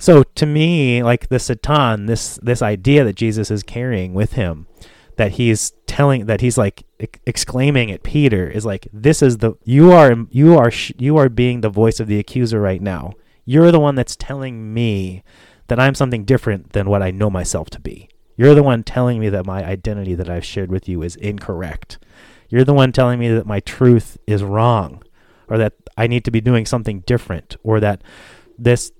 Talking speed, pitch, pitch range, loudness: 200 wpm, 115 Hz, 100-125 Hz, -16 LUFS